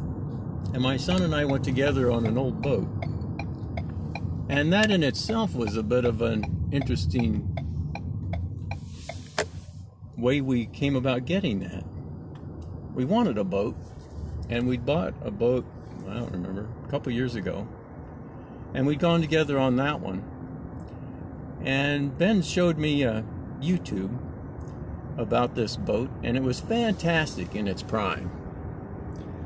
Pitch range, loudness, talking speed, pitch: 95-140 Hz, -27 LUFS, 135 wpm, 120 Hz